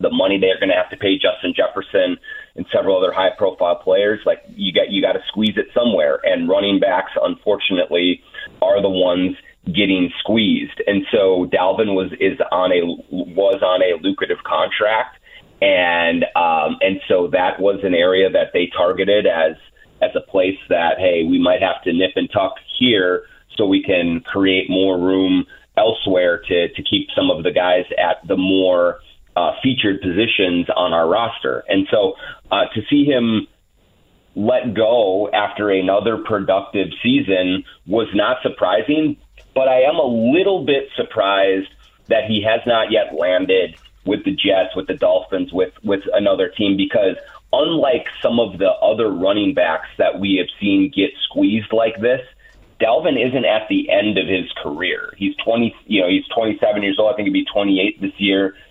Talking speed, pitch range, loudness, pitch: 175 wpm, 95-150 Hz, -17 LUFS, 100 Hz